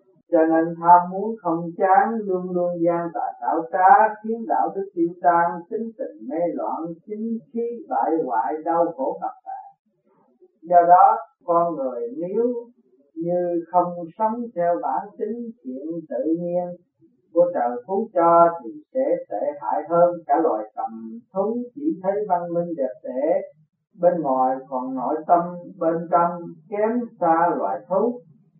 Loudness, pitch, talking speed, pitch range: -22 LUFS, 175 Hz, 155 wpm, 170-220 Hz